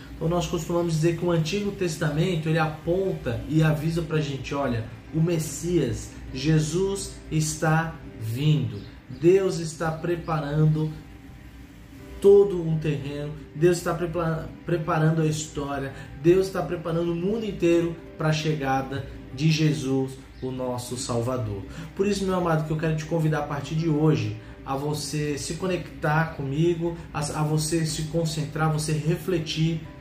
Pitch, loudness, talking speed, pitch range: 155 Hz, -25 LUFS, 145 wpm, 140-170 Hz